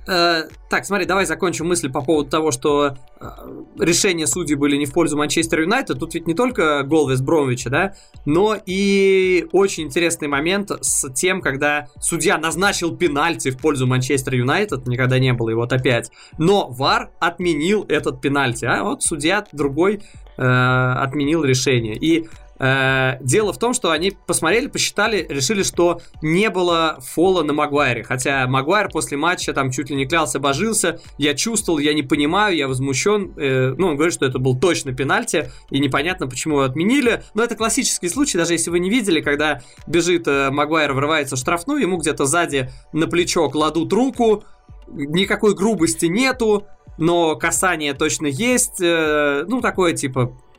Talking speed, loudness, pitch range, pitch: 160 wpm, -18 LUFS, 140-180 Hz, 155 Hz